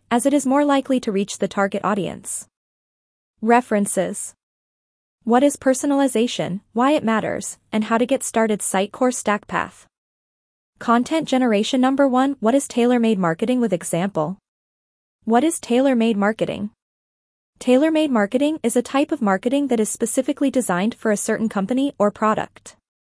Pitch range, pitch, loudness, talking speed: 205-265 Hz, 235 Hz, -20 LUFS, 145 wpm